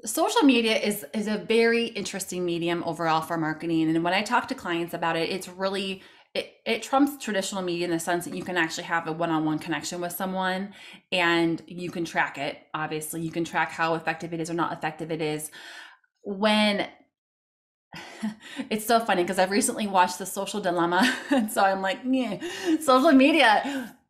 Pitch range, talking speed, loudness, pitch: 165-225 Hz, 185 wpm, -25 LUFS, 185 Hz